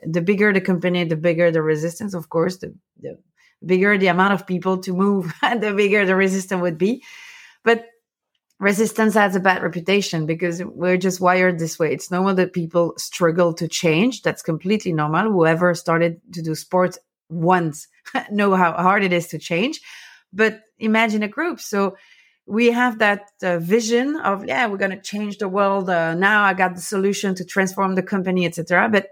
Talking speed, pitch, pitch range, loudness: 190 wpm, 190 Hz, 175-205 Hz, -19 LUFS